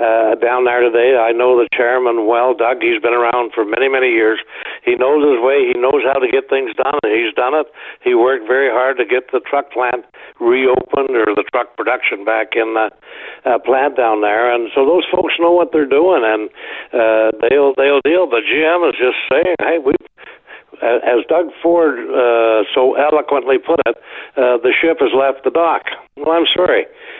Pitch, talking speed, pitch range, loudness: 135 Hz, 205 wpm, 120-185 Hz, -14 LUFS